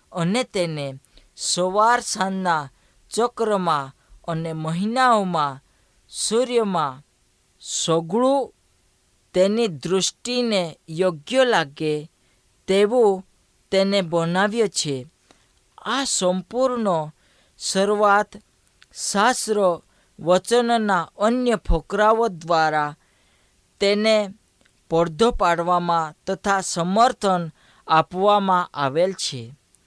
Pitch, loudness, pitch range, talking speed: 185 Hz, -21 LUFS, 160-210 Hz, 65 wpm